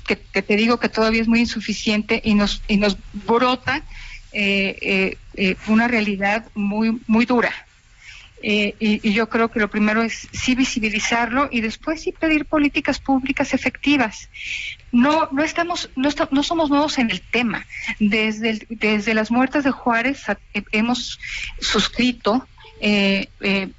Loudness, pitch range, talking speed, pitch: -20 LUFS, 210-260 Hz, 160 wpm, 230 Hz